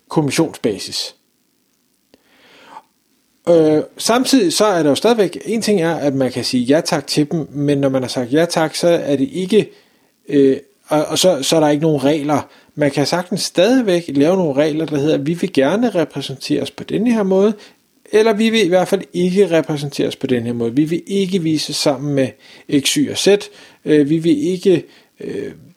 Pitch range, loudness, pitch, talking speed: 145-200 Hz, -16 LUFS, 160 Hz, 200 wpm